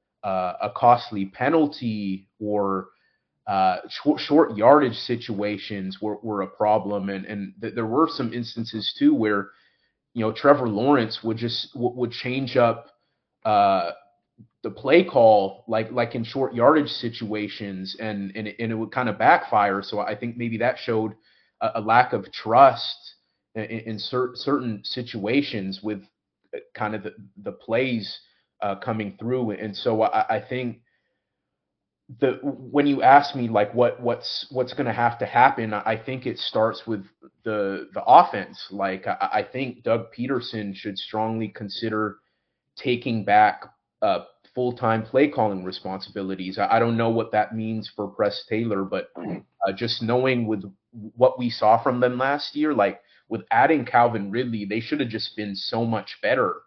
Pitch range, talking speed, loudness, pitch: 105-125 Hz, 165 wpm, -23 LUFS, 115 Hz